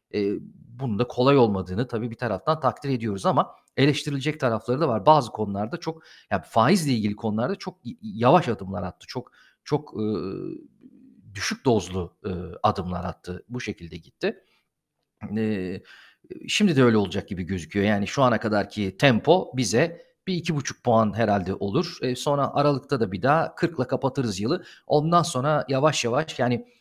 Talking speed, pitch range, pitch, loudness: 155 wpm, 105-150 Hz, 125 Hz, -24 LUFS